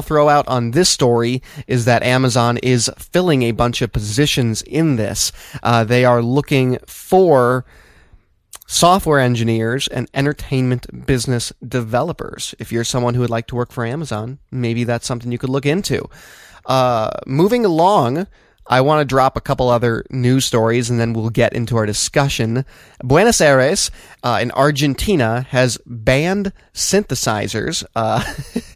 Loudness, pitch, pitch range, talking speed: -16 LUFS, 125 Hz, 120-140 Hz, 150 wpm